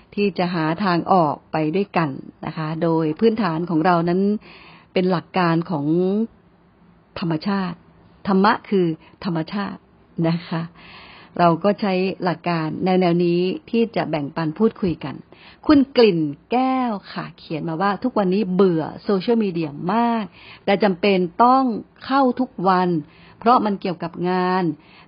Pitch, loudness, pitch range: 185 Hz, -20 LUFS, 165-205 Hz